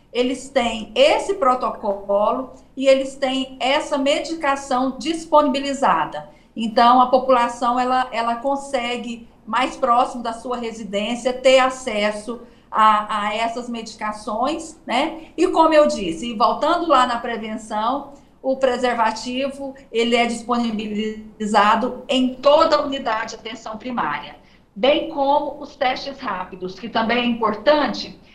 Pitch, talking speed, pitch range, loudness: 245 Hz, 120 wpm, 225-275 Hz, -20 LUFS